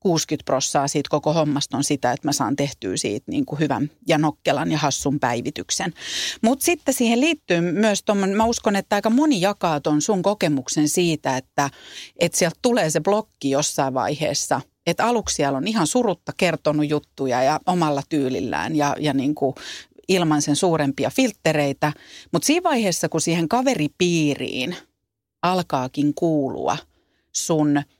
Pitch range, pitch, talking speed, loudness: 145-195 Hz, 155 Hz, 155 wpm, -21 LUFS